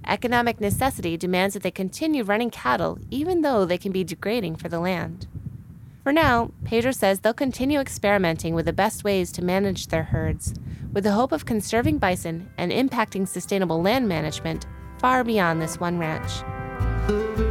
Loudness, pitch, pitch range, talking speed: -24 LUFS, 195 Hz, 175-235 Hz, 165 wpm